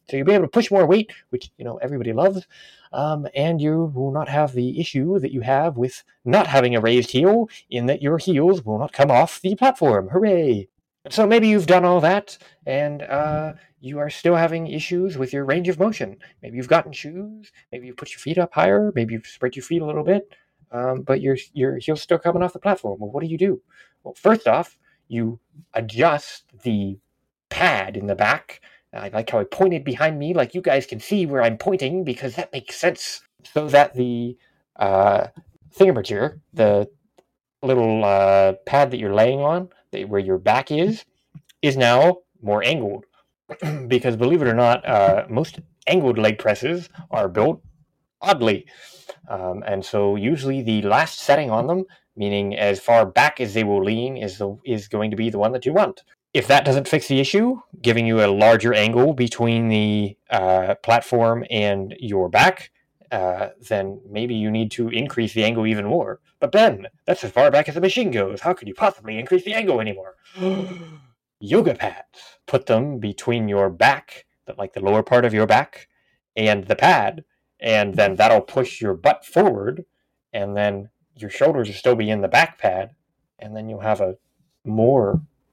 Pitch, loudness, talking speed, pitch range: 135 Hz, -20 LUFS, 190 wpm, 110-165 Hz